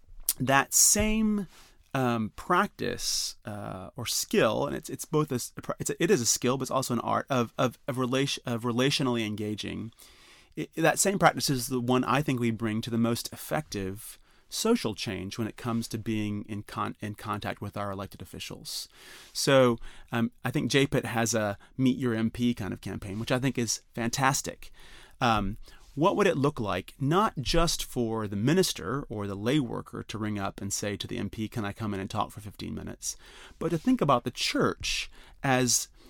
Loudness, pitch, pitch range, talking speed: -28 LUFS, 120 Hz, 105-135 Hz, 195 wpm